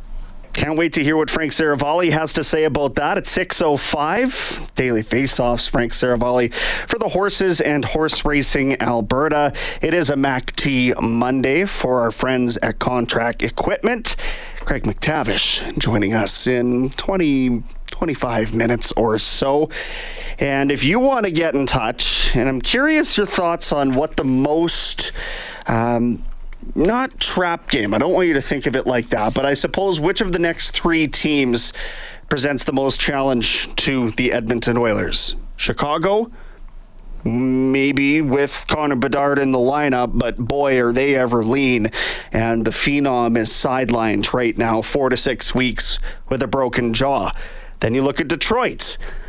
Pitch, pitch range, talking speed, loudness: 135 Hz, 120-155 Hz, 155 wpm, -17 LUFS